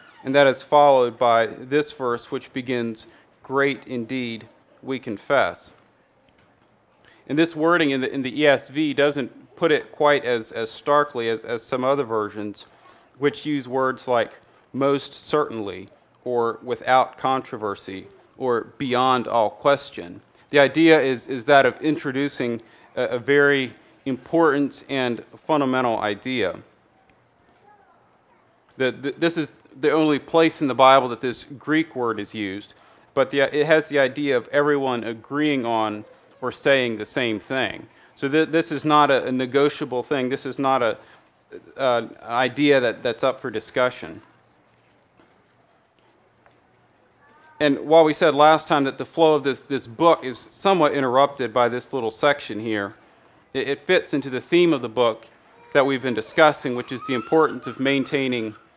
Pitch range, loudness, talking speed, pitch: 120-145 Hz, -21 LUFS, 155 wpm, 135 Hz